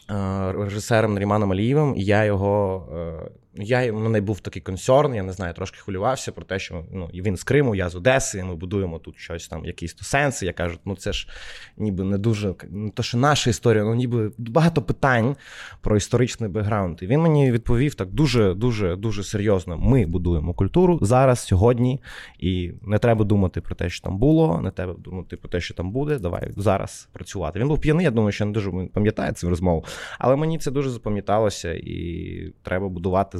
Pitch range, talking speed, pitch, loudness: 90-120 Hz, 200 wpm, 100 Hz, -22 LUFS